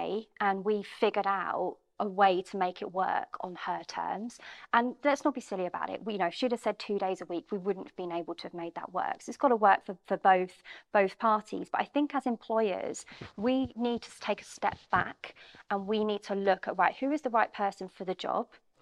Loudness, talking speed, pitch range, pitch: -31 LUFS, 250 wpm, 190-235 Hz, 205 Hz